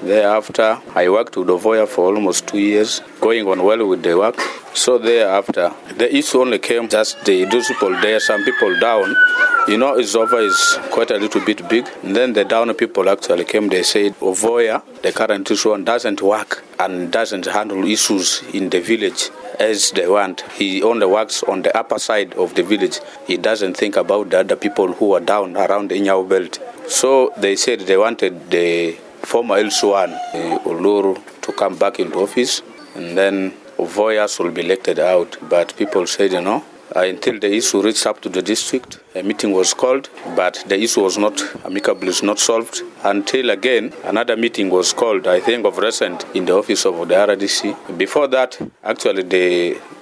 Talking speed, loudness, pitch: 185 wpm, -16 LUFS, 340 Hz